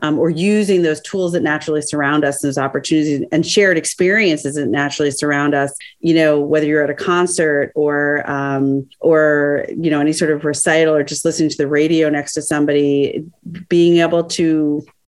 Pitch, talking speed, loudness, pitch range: 150 Hz, 185 wpm, -16 LUFS, 145-165 Hz